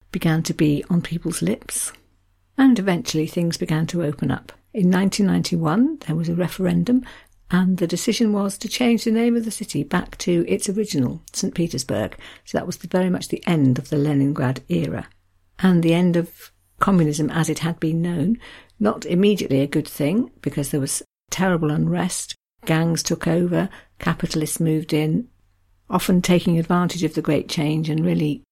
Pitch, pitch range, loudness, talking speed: 170 Hz, 155-185 Hz, -21 LUFS, 175 wpm